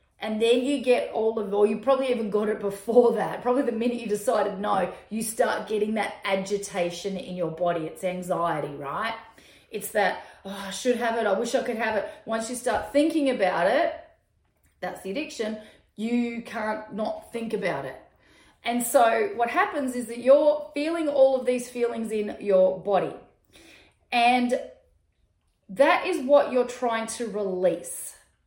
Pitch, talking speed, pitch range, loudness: 225 Hz, 175 wpm, 200-245 Hz, -25 LUFS